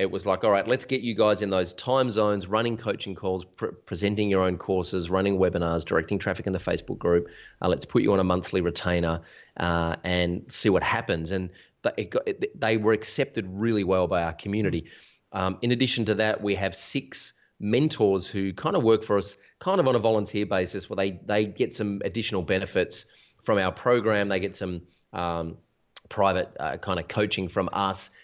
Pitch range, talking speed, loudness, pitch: 90-110 Hz, 205 wpm, -26 LUFS, 100 Hz